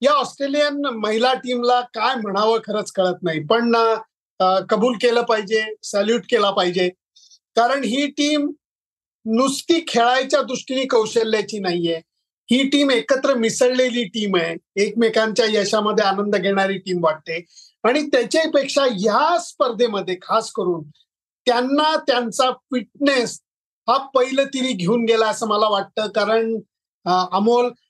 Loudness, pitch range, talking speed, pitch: -19 LUFS, 205-260 Hz, 120 wpm, 230 Hz